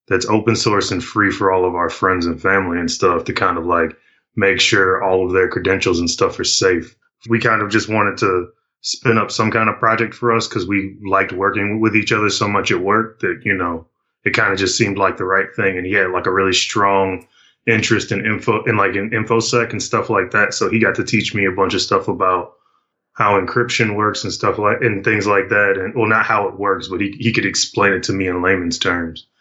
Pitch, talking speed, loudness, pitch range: 100 Hz, 245 wpm, -16 LUFS, 95-115 Hz